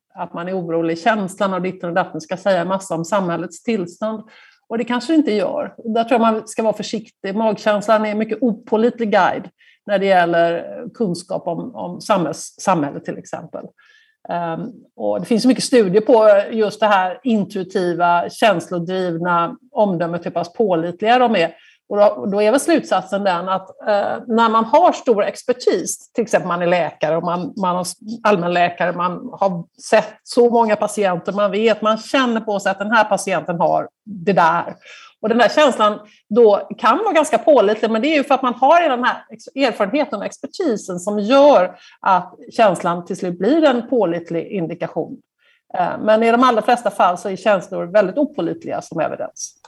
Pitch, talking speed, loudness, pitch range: 210 Hz, 175 wpm, -17 LUFS, 180-235 Hz